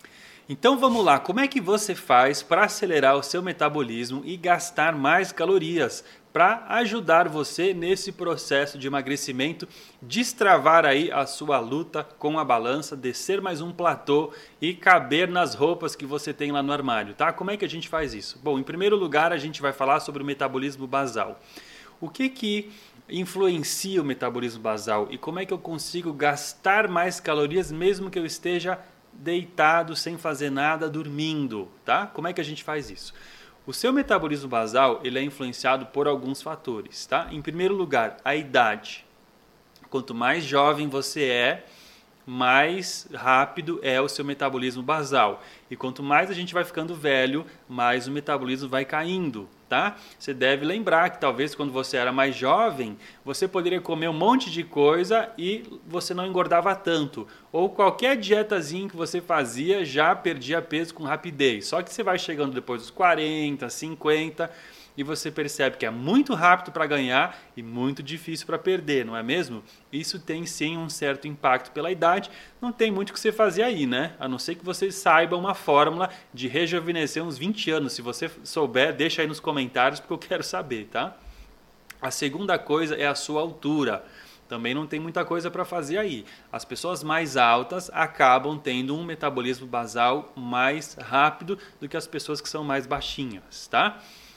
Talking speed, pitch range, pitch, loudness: 175 wpm, 140-180 Hz, 155 Hz, -25 LUFS